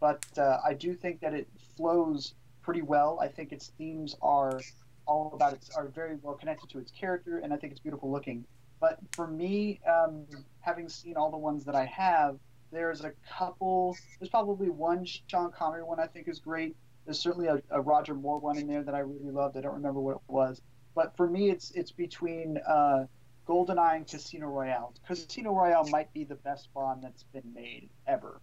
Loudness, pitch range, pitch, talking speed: -32 LUFS, 135-170 Hz, 150 Hz, 205 wpm